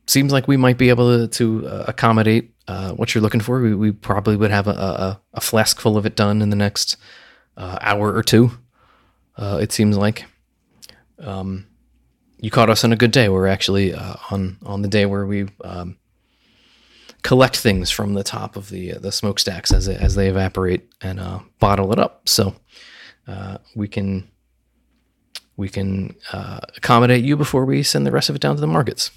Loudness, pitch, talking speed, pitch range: -18 LUFS, 105 Hz, 200 wpm, 95-115 Hz